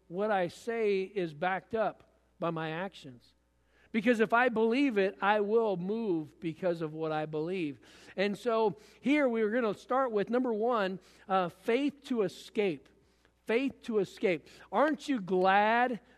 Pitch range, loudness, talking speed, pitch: 180-235 Hz, -31 LUFS, 160 wpm, 205 Hz